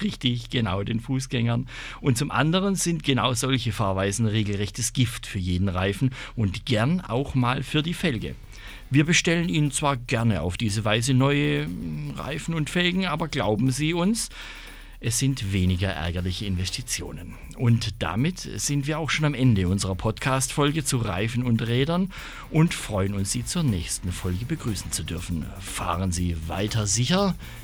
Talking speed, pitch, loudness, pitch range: 155 wpm, 120 Hz, -25 LUFS, 100-145 Hz